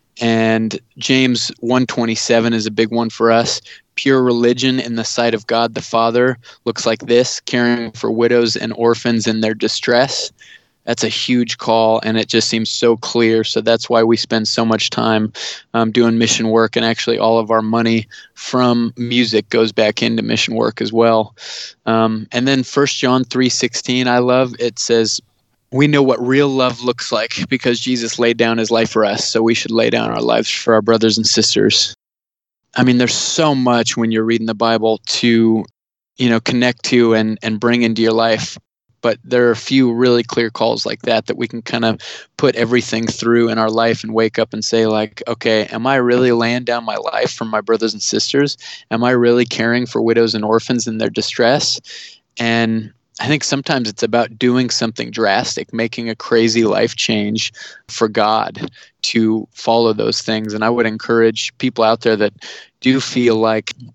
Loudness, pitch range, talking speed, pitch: -15 LUFS, 115-120 Hz, 195 wpm, 115 Hz